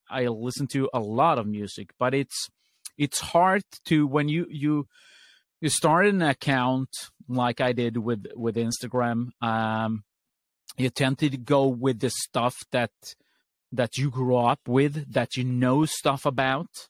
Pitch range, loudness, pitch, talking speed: 120-145 Hz, -25 LUFS, 130 Hz, 155 wpm